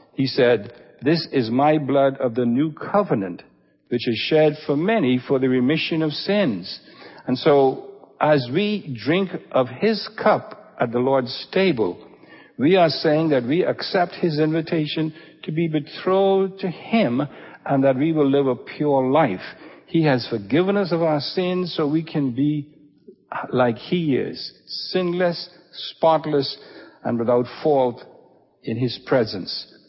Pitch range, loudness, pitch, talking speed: 135-175 Hz, -21 LUFS, 155 Hz, 150 wpm